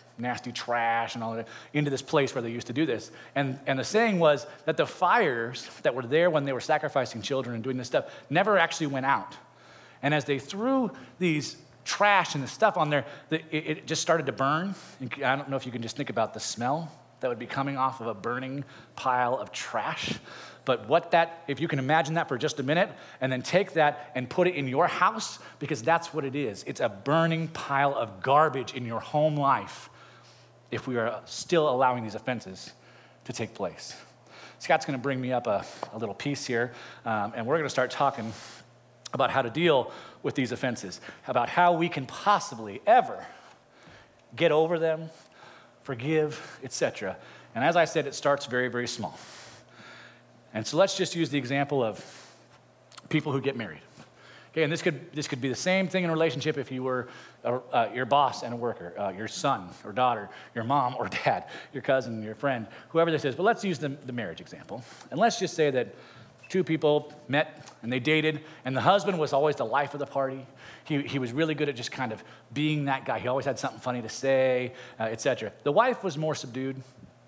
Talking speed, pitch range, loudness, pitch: 215 wpm, 125-155 Hz, -28 LUFS, 140 Hz